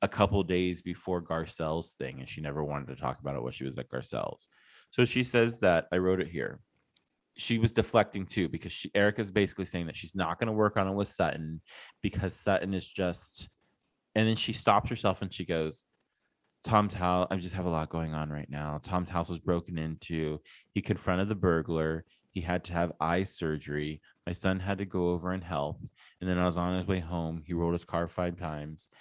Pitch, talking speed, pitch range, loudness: 90 Hz, 225 wpm, 80-95 Hz, -31 LUFS